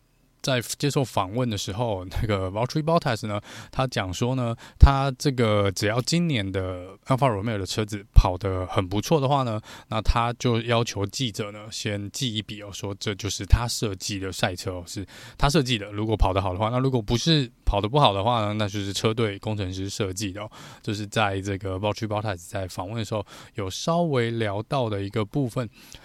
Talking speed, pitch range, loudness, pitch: 350 characters per minute, 100-125 Hz, -25 LUFS, 110 Hz